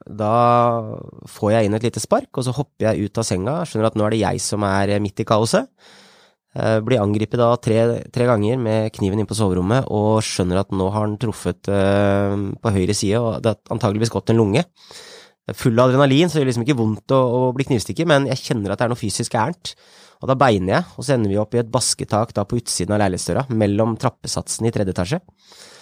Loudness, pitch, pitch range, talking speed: -19 LUFS, 110 Hz, 105-125 Hz, 225 wpm